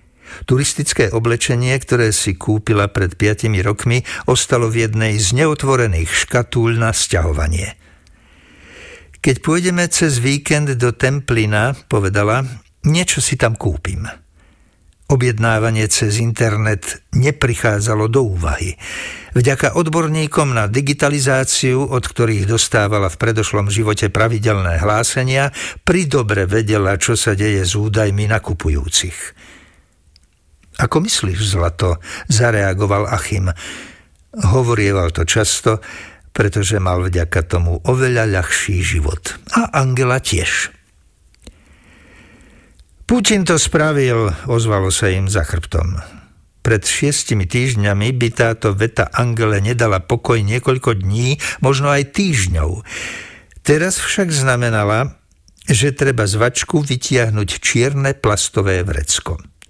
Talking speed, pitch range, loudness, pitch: 105 wpm, 95-130 Hz, -16 LUFS, 110 Hz